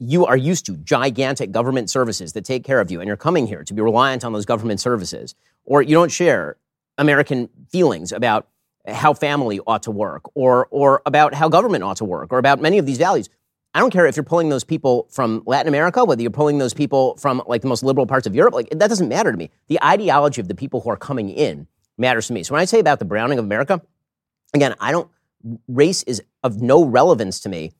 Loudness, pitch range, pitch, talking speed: -18 LUFS, 115-150 Hz, 135 Hz, 235 wpm